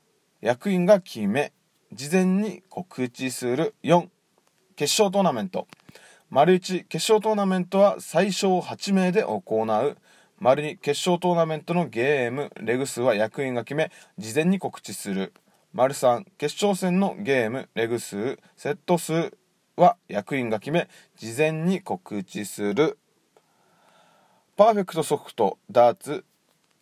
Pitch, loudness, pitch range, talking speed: 170 Hz, -24 LUFS, 130-190 Hz, 215 characters per minute